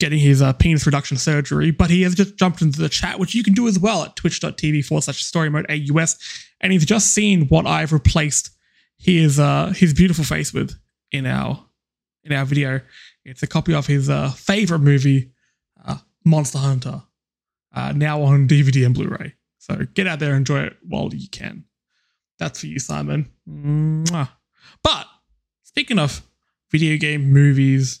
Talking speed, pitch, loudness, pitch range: 180 wpm, 150 Hz, -18 LUFS, 135-165 Hz